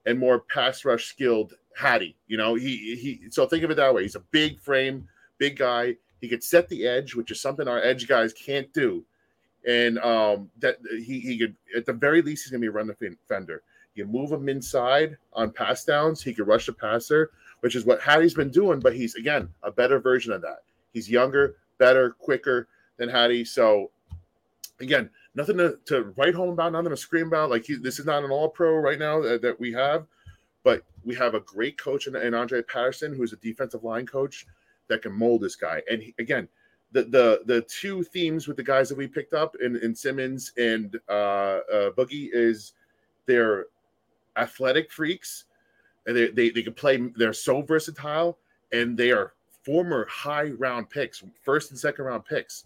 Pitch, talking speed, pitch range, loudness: 130 Hz, 195 wpm, 115-150 Hz, -25 LUFS